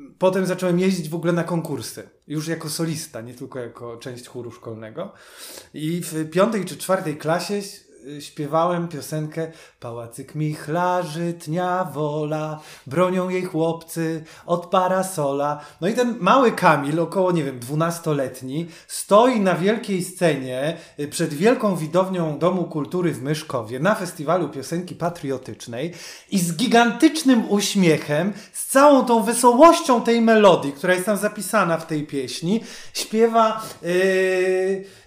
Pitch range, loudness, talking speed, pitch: 150-190 Hz, -21 LUFS, 130 wpm, 170 Hz